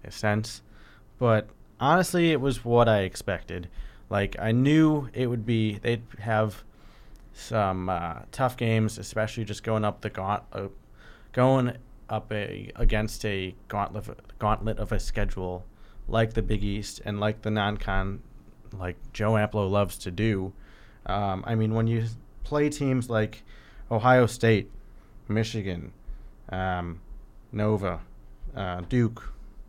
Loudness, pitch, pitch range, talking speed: -27 LUFS, 110 Hz, 100-115 Hz, 135 wpm